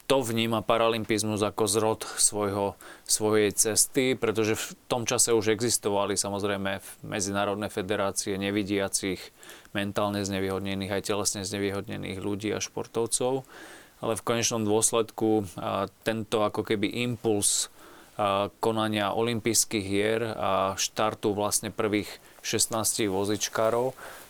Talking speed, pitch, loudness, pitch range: 105 wpm, 105 Hz, -27 LUFS, 100-115 Hz